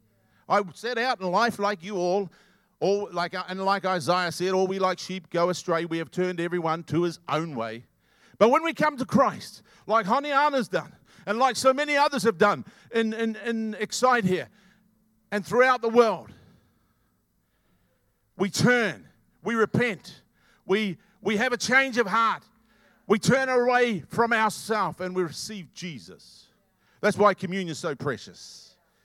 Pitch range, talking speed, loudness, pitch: 180-235 Hz, 165 wpm, -25 LUFS, 205 Hz